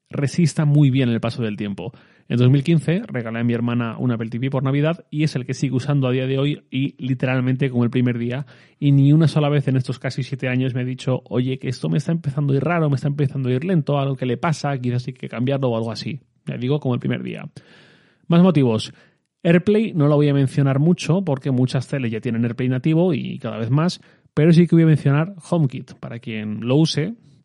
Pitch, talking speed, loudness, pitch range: 135 Hz, 240 wpm, -20 LUFS, 125-150 Hz